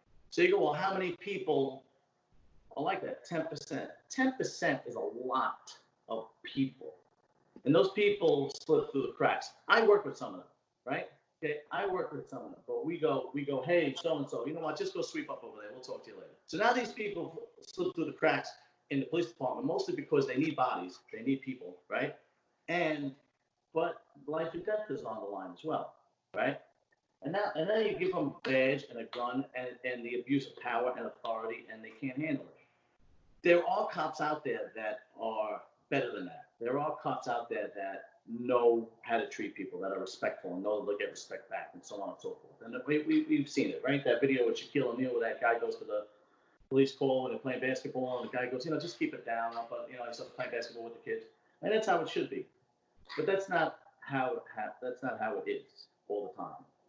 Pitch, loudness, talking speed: 160 Hz, -34 LUFS, 230 wpm